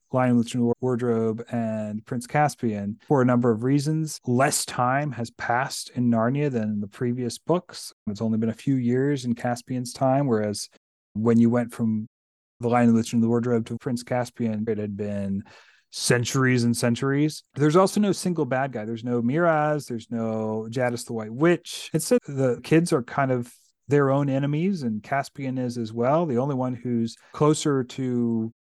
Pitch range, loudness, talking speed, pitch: 115-140 Hz, -24 LUFS, 180 wpm, 120 Hz